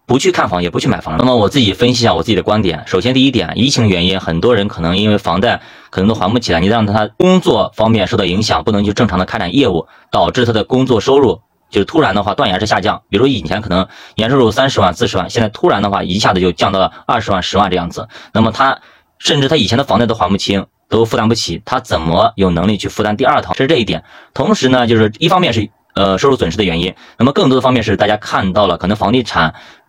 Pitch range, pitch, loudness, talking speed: 95-120 Hz, 105 Hz, -13 LUFS, 400 characters per minute